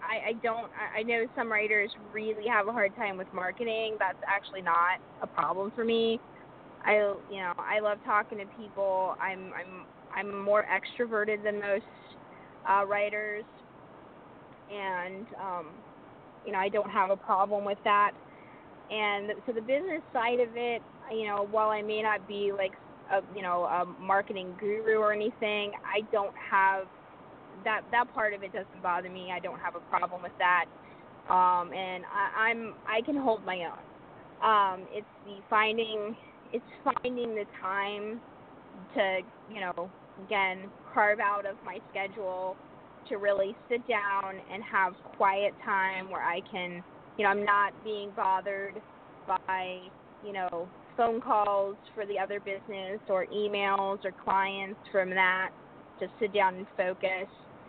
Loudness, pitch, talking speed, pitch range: -31 LUFS, 200 Hz, 160 wpm, 190-215 Hz